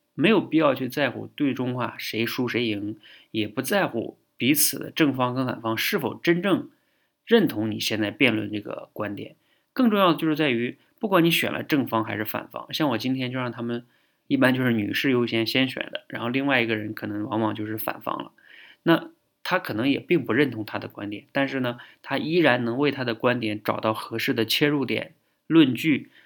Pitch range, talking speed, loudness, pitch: 110-145 Hz, 295 characters per minute, -24 LUFS, 120 Hz